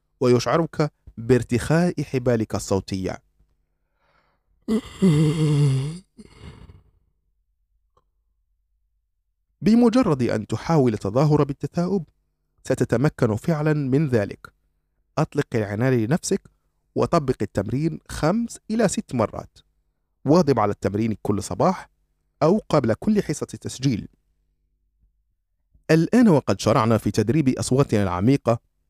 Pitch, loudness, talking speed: 115 Hz, -22 LUFS, 80 wpm